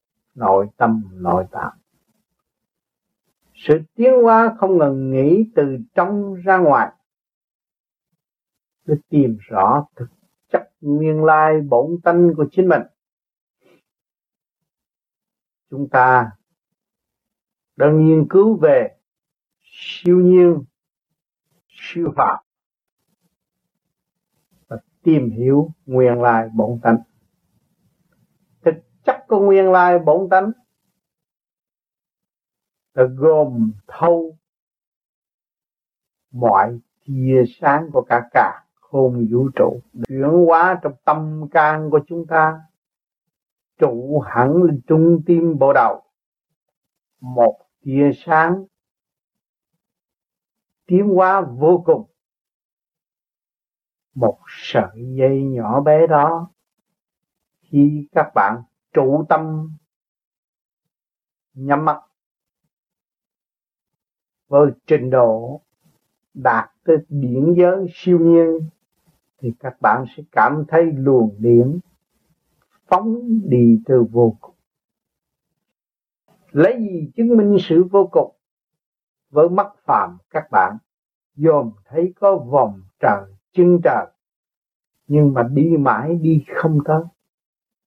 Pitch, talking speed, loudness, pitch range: 155 Hz, 100 wpm, -16 LUFS, 130-175 Hz